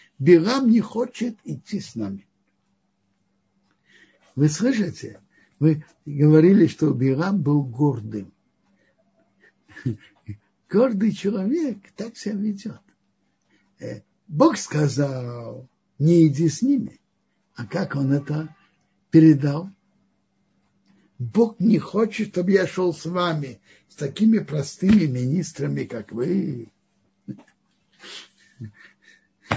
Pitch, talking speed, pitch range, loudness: 160 Hz, 90 wpm, 135-205 Hz, -21 LUFS